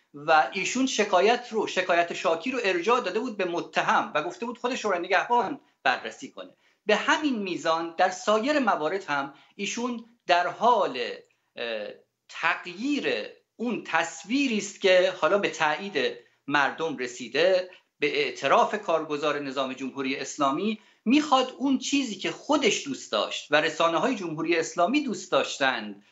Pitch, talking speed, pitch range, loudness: 190 Hz, 140 wpm, 165-255 Hz, -26 LUFS